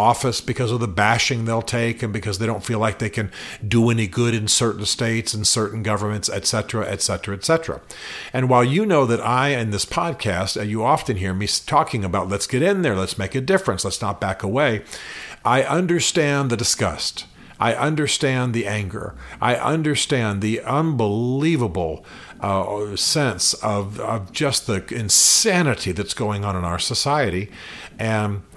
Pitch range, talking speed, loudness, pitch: 105-130 Hz, 170 wpm, -20 LUFS, 115 Hz